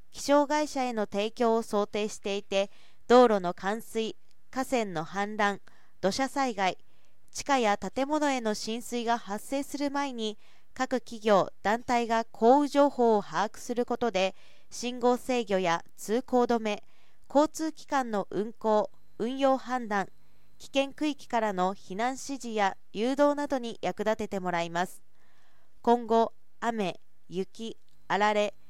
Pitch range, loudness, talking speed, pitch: 205-255 Hz, -29 LUFS, 240 characters per minute, 225 Hz